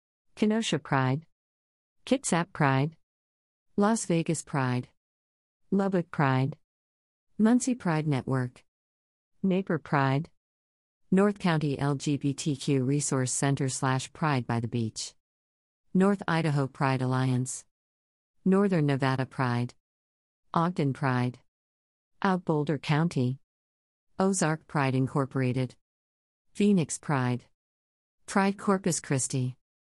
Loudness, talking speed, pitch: -28 LUFS, 90 wpm, 130 Hz